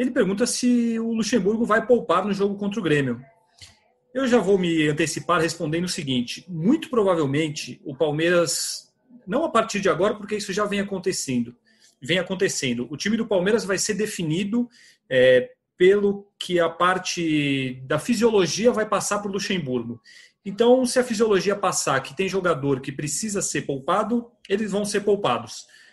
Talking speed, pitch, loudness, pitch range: 165 wpm, 195 Hz, -22 LUFS, 165-225 Hz